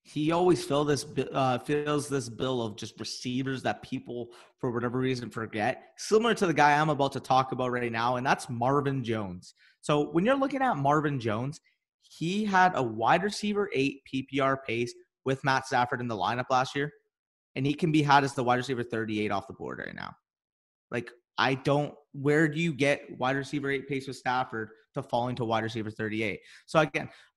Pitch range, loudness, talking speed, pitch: 120-150 Hz, -29 LUFS, 200 wpm, 135 Hz